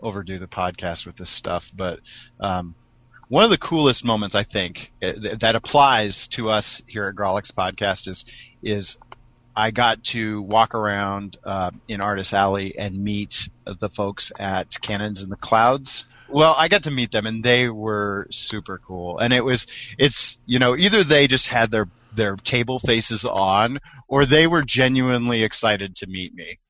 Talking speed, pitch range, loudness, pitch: 175 wpm, 100-125 Hz, -20 LUFS, 110 Hz